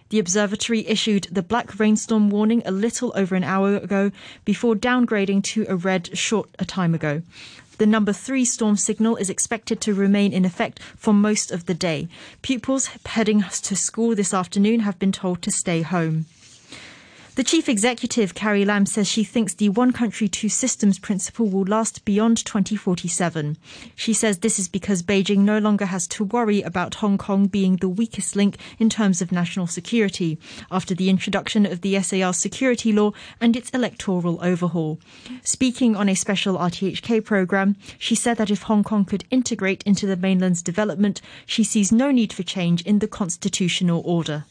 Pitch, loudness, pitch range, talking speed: 205 Hz, -21 LUFS, 190-220 Hz, 175 wpm